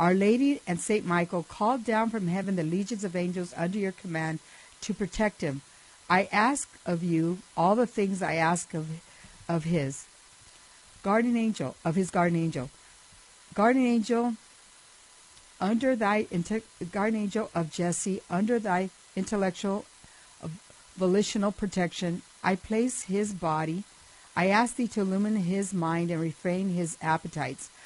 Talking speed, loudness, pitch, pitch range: 140 wpm, -28 LUFS, 190 Hz, 170-210 Hz